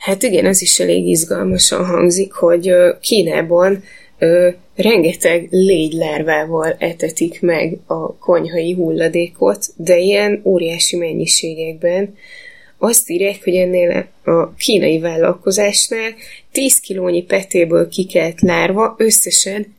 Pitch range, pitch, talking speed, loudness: 170-200 Hz, 180 Hz, 100 wpm, -14 LUFS